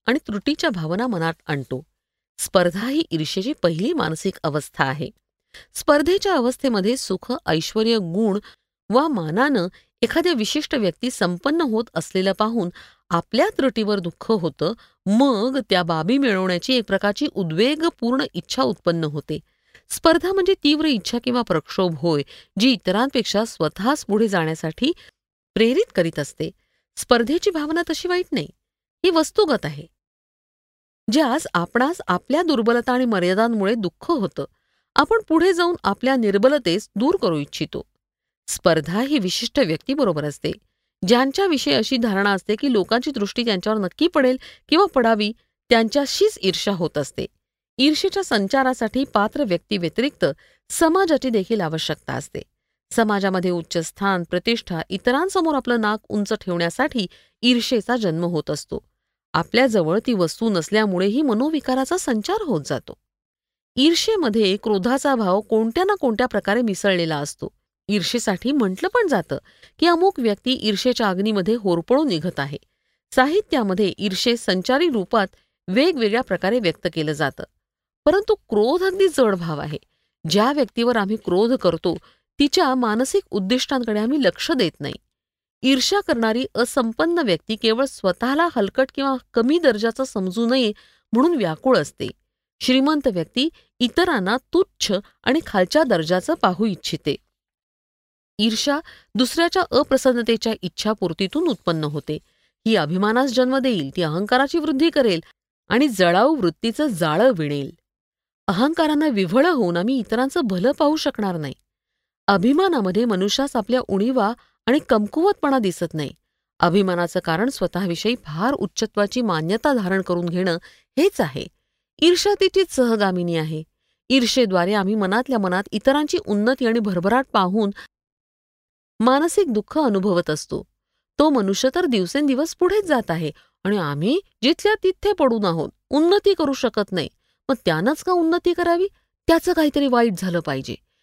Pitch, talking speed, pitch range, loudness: 230 Hz, 125 wpm, 185-275 Hz, -20 LUFS